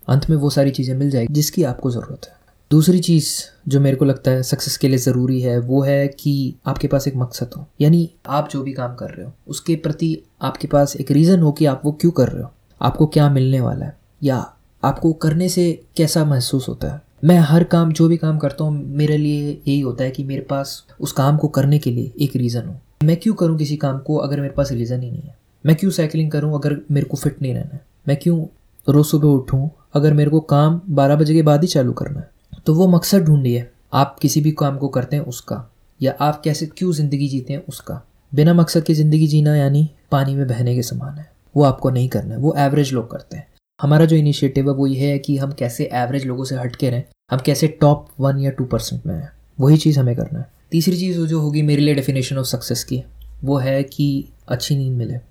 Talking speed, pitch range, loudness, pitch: 240 wpm, 135-155 Hz, -18 LUFS, 145 Hz